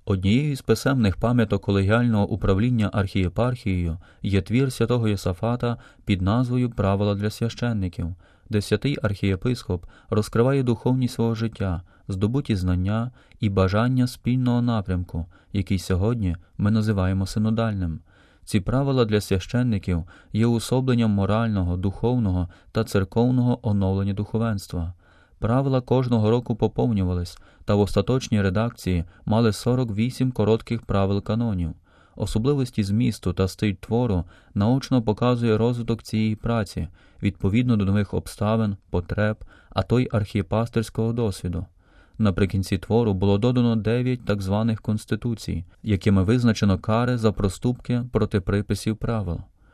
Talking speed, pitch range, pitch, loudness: 115 wpm, 95-115 Hz, 105 Hz, -24 LUFS